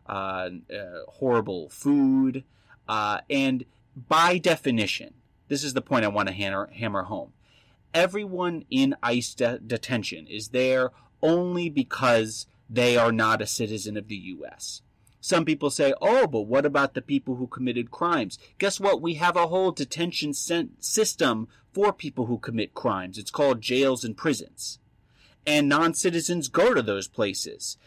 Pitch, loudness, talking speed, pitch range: 130 Hz, -25 LUFS, 155 wpm, 115-160 Hz